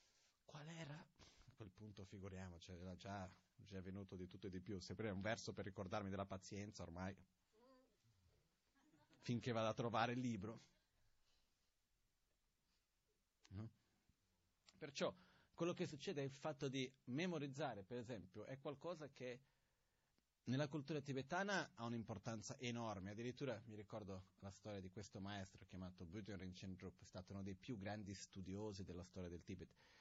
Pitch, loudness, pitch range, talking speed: 105 Hz, -51 LUFS, 95-125 Hz, 145 wpm